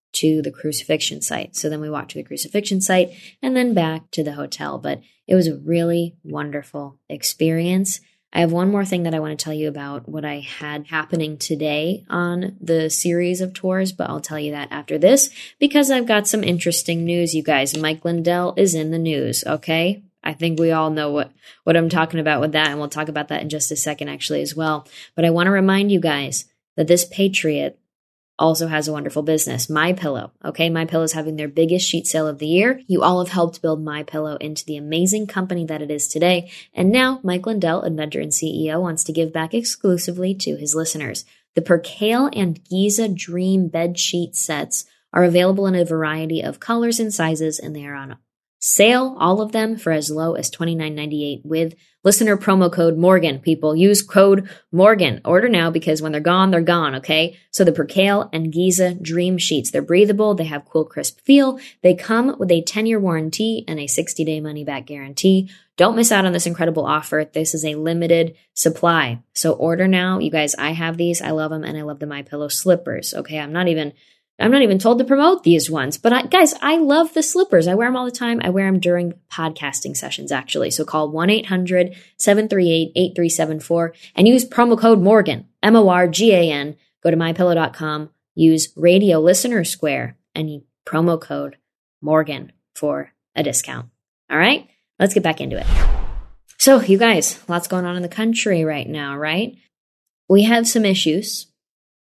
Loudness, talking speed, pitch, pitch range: -18 LUFS, 205 wpm, 170 Hz, 155-190 Hz